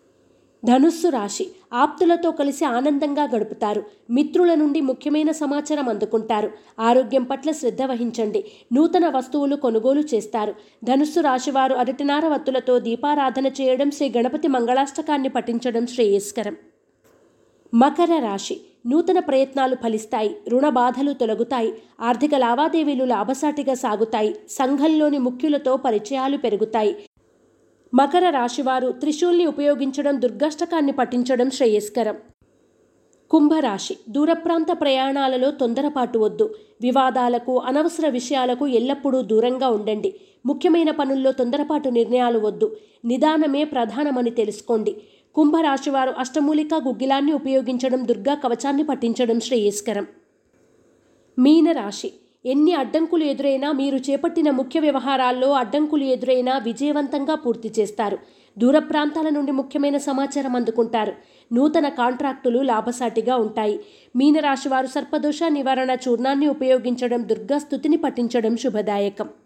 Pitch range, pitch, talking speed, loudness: 240-295 Hz, 265 Hz, 95 wpm, -21 LUFS